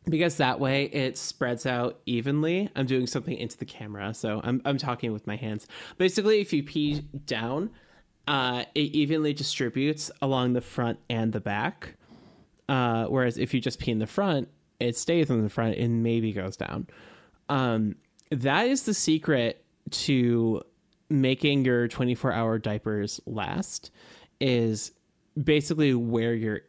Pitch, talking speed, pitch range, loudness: 130 Hz, 155 wpm, 115-150 Hz, -27 LUFS